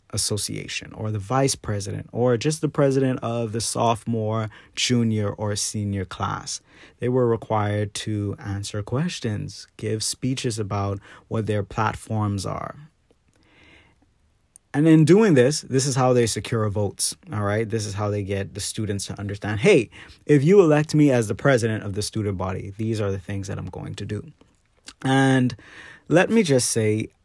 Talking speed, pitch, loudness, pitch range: 165 wpm, 110 Hz, -23 LUFS, 105-130 Hz